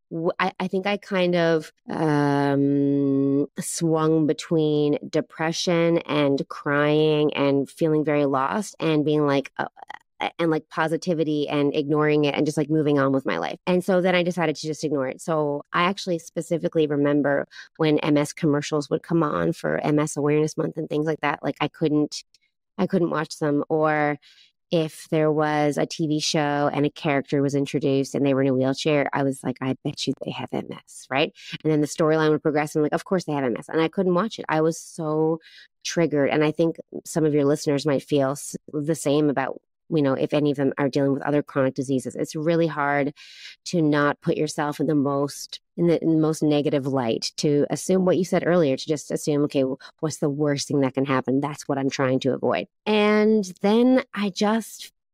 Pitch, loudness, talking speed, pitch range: 150 Hz, -23 LUFS, 205 wpm, 145-165 Hz